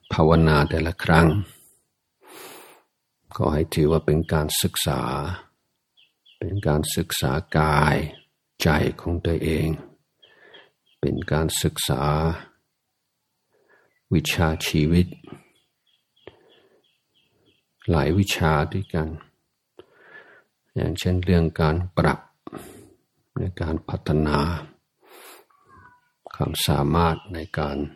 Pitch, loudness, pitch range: 80 Hz, -23 LUFS, 75-90 Hz